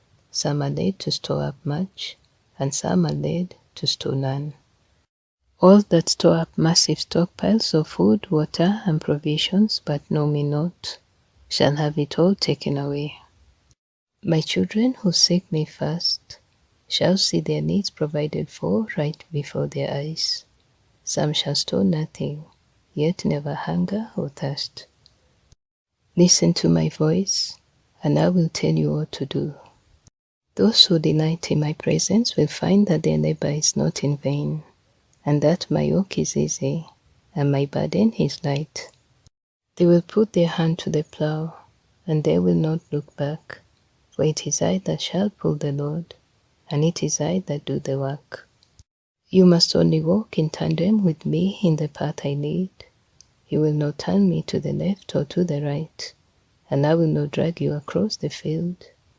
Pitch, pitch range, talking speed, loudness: 155 Hz, 145-175 Hz, 165 wpm, -22 LUFS